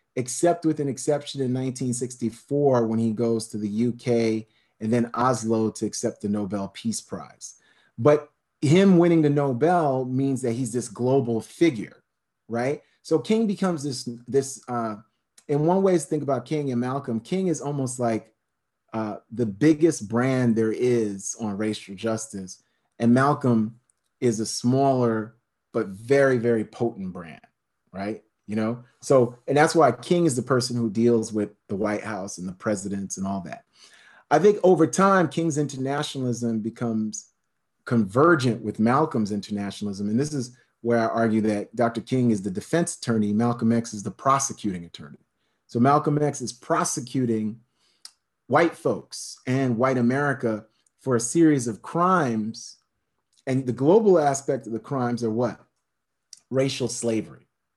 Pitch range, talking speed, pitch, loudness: 110-140 Hz, 155 wpm, 120 Hz, -24 LUFS